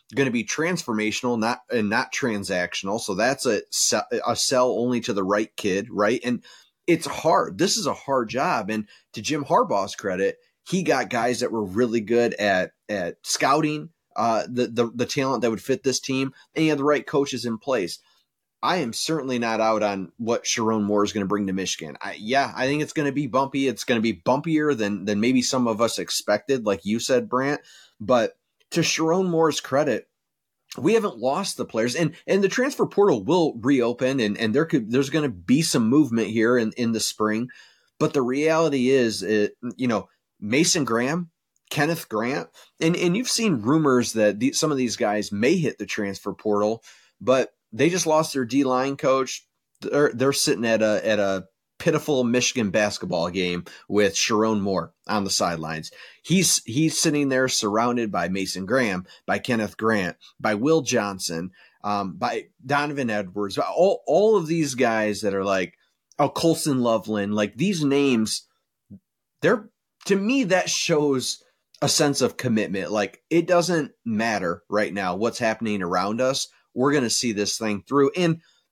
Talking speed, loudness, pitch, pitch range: 185 wpm, -23 LUFS, 125 Hz, 110-150 Hz